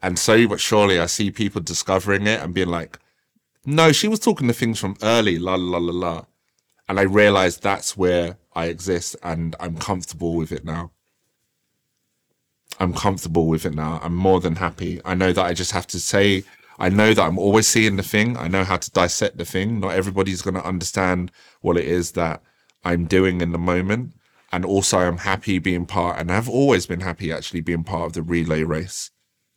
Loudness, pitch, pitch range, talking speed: -20 LUFS, 90 Hz, 85-100 Hz, 205 wpm